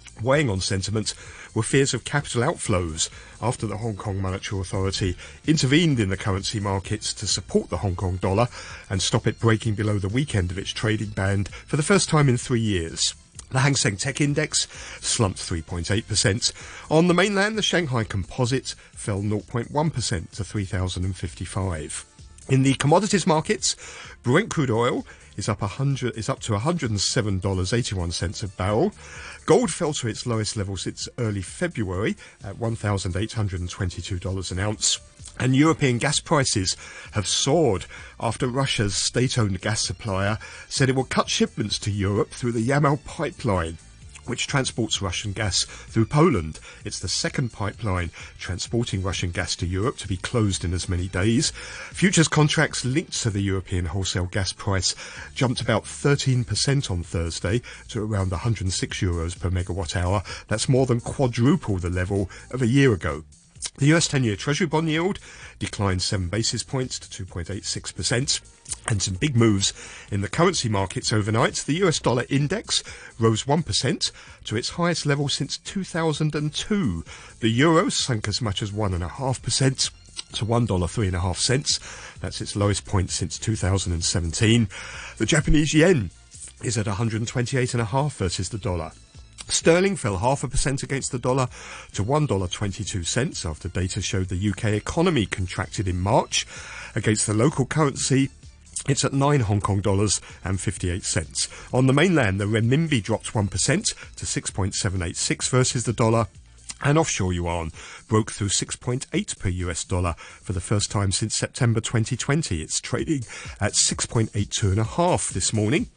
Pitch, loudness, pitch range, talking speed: 110 Hz, -24 LUFS, 95-130 Hz, 165 wpm